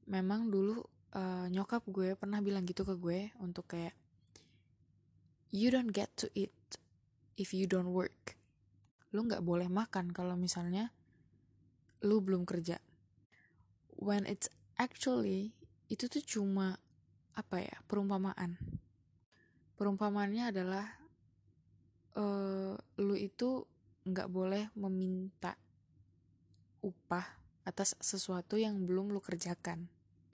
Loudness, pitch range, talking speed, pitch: -38 LUFS, 180-205 Hz, 105 wpm, 195 Hz